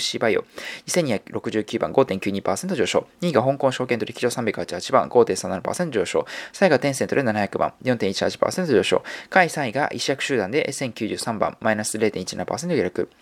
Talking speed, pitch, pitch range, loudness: 185 characters per minute, 110 Hz, 105-125 Hz, -23 LUFS